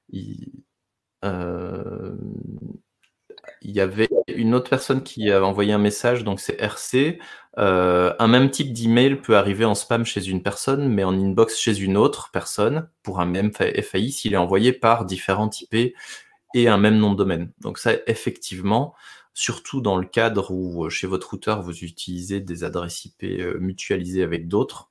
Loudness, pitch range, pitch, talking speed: -22 LUFS, 95-120 Hz, 105 Hz, 170 wpm